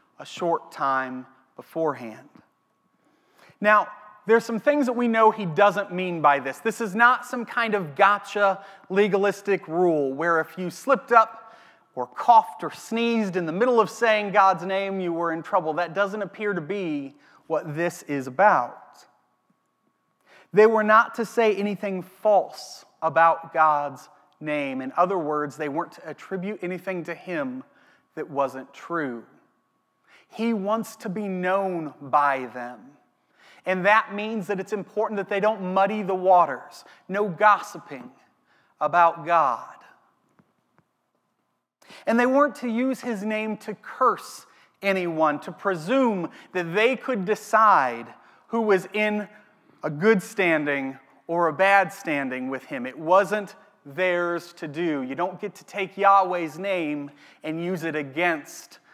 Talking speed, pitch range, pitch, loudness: 145 wpm, 165-215 Hz, 195 Hz, -23 LUFS